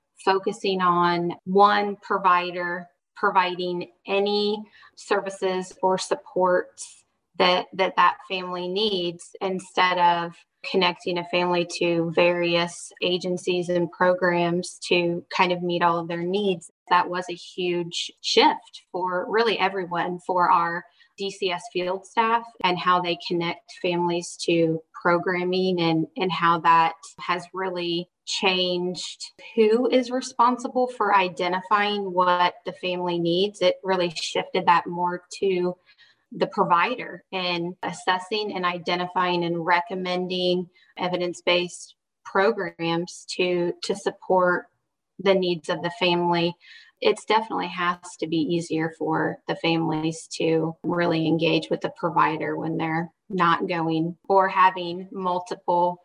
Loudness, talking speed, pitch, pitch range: -24 LUFS, 120 wpm, 180 Hz, 175-190 Hz